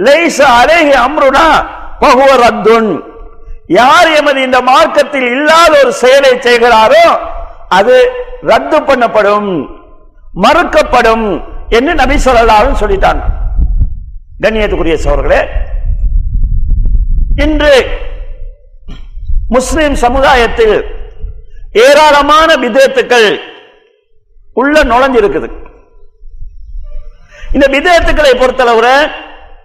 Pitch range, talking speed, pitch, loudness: 225-325 Hz, 40 wpm, 270 Hz, -8 LUFS